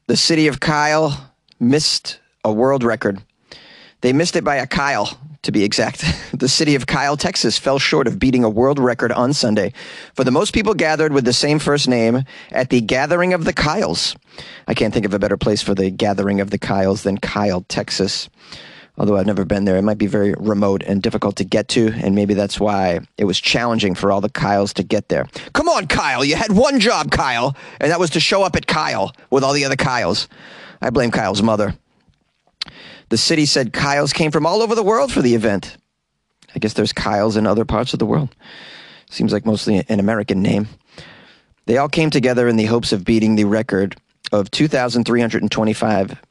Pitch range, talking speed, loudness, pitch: 105-145 Hz, 205 wpm, -17 LUFS, 115 Hz